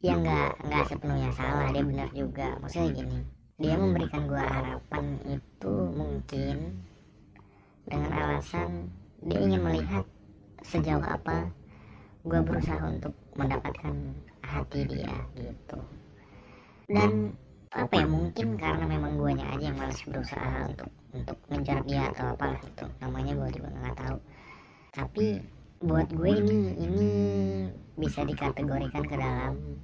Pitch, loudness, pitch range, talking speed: 80 Hz, -31 LUFS, 70-95 Hz, 125 wpm